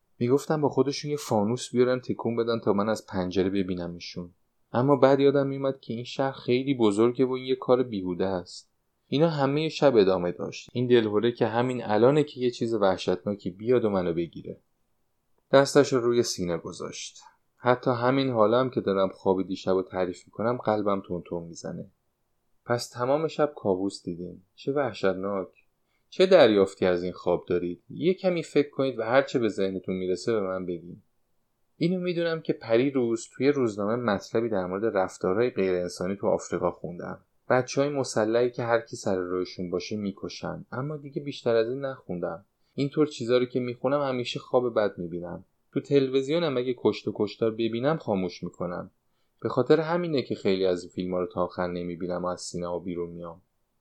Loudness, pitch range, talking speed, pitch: -27 LUFS, 95-135 Hz, 175 wpm, 115 Hz